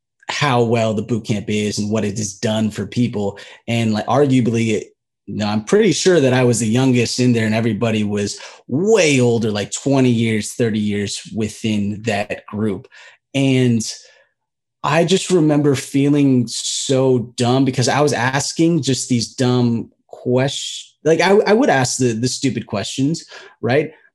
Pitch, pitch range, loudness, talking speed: 120 Hz, 110-135 Hz, -17 LUFS, 165 wpm